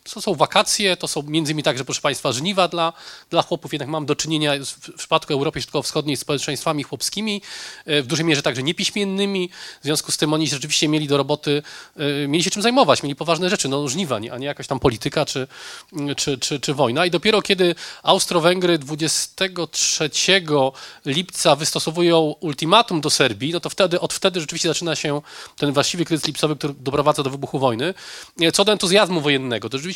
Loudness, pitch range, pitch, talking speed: -20 LUFS, 145-175 Hz, 155 Hz, 185 wpm